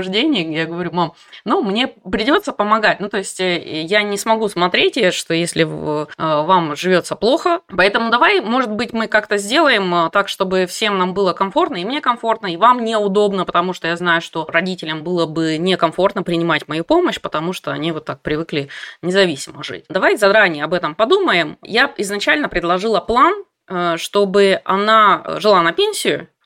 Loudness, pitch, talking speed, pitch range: -16 LUFS, 190 Hz, 165 wpm, 170-220 Hz